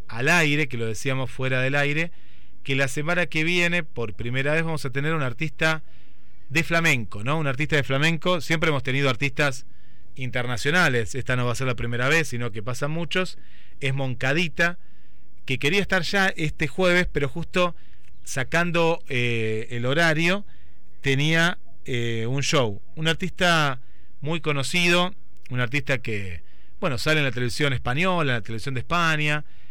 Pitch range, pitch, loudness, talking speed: 120-165 Hz, 140 Hz, -24 LUFS, 165 wpm